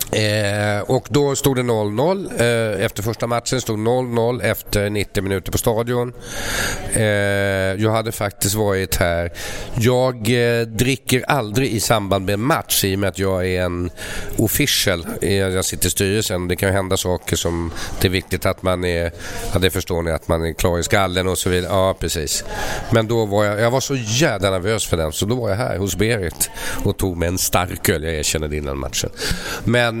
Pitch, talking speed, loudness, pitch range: 100 Hz, 200 wpm, -19 LUFS, 90-115 Hz